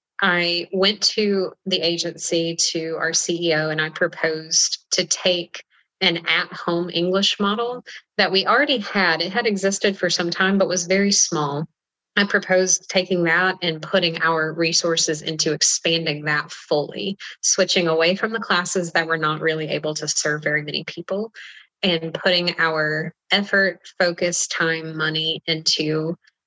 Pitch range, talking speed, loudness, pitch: 160-190 Hz, 150 wpm, -20 LUFS, 175 Hz